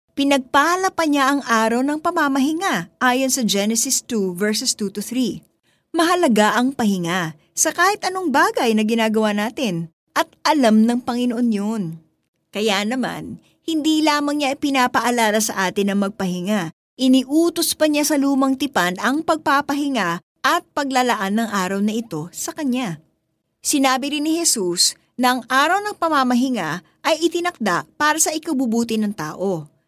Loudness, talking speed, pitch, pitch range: -19 LUFS, 145 wpm, 250 Hz, 210-295 Hz